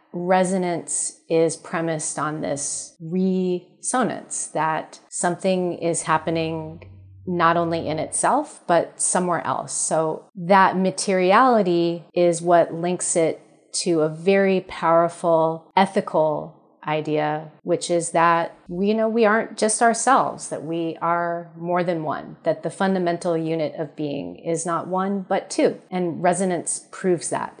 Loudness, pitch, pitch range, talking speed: -22 LUFS, 170 Hz, 165-185 Hz, 130 wpm